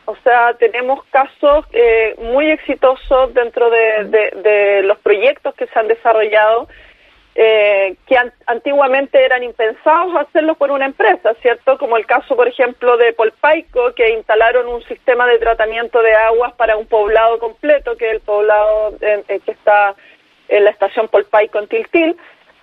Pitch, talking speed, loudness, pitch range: 240 Hz, 155 wpm, -13 LUFS, 220-275 Hz